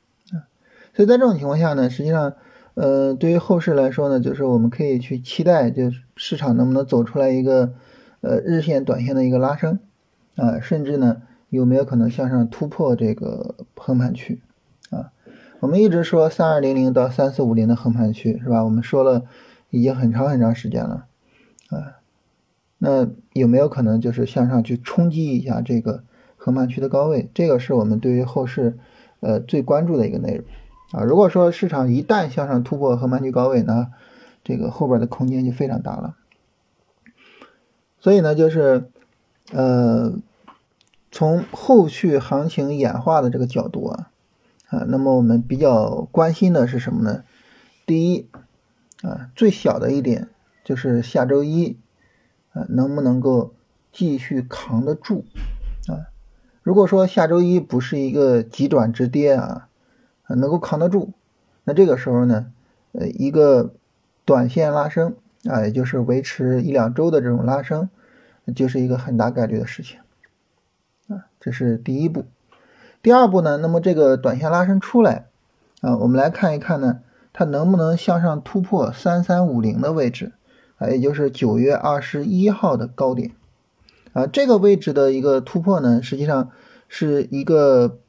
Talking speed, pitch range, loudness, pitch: 250 characters per minute, 125-170 Hz, -19 LUFS, 135 Hz